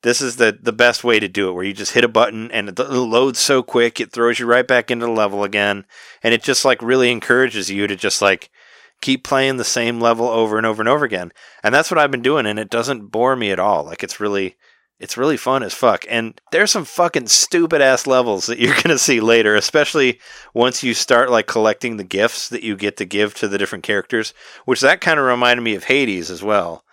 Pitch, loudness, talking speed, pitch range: 120 Hz, -16 LUFS, 250 wpm, 105-130 Hz